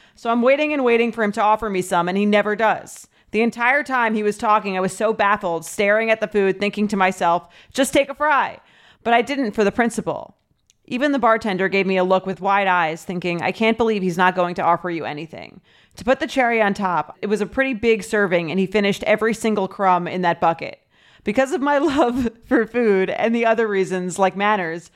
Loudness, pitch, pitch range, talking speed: -19 LUFS, 210 Hz, 185-230 Hz, 230 wpm